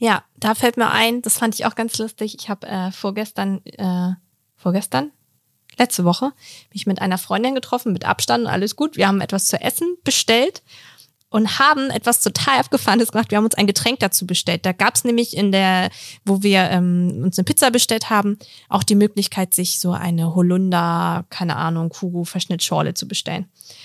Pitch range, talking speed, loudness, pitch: 180-230 Hz, 185 wpm, -18 LUFS, 200 Hz